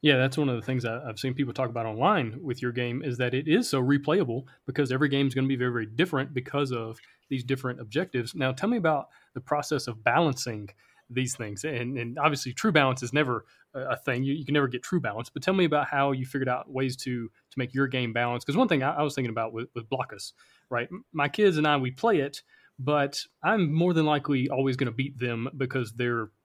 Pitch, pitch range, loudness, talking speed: 130 Hz, 125-145 Hz, -28 LUFS, 245 wpm